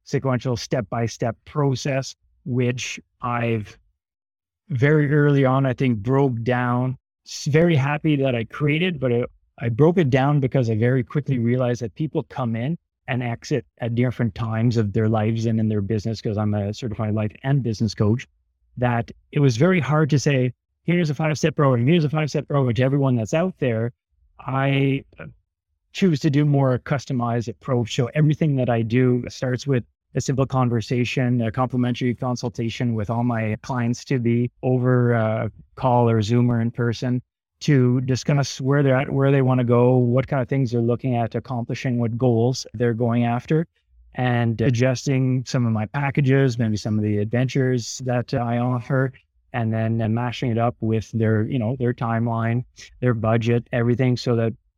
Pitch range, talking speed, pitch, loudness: 115-135 Hz, 180 wpm, 125 Hz, -22 LUFS